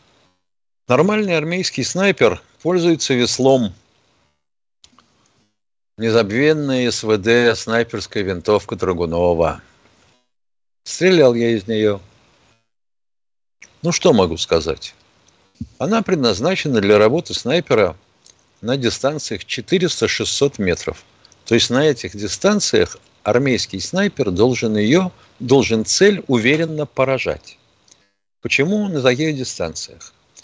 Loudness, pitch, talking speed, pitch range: -17 LUFS, 120 Hz, 85 wpm, 105-150 Hz